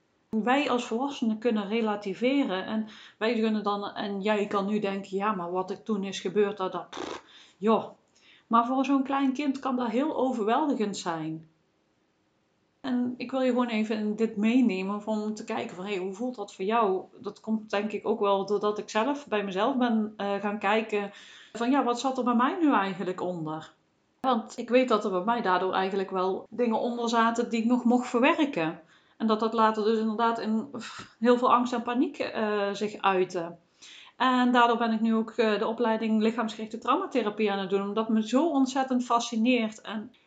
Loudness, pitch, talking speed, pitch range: -27 LUFS, 220 Hz, 195 wpm, 200-245 Hz